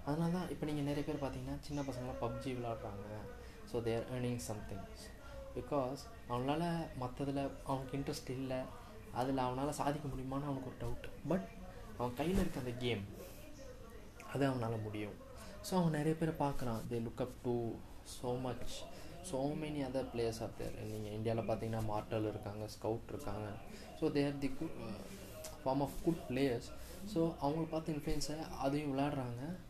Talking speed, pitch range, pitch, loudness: 150 wpm, 115-145 Hz, 130 Hz, -40 LUFS